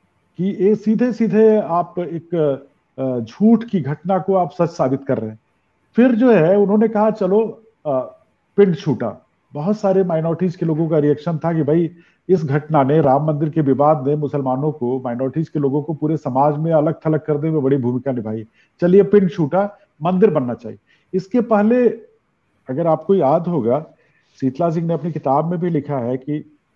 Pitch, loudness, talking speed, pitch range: 160 Hz, -18 LUFS, 180 wpm, 145-190 Hz